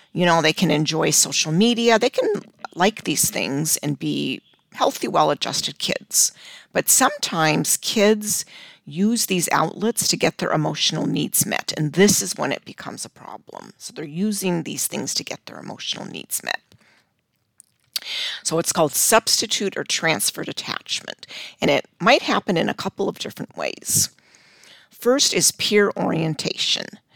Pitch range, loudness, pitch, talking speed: 160-210 Hz, -20 LUFS, 180 Hz, 150 wpm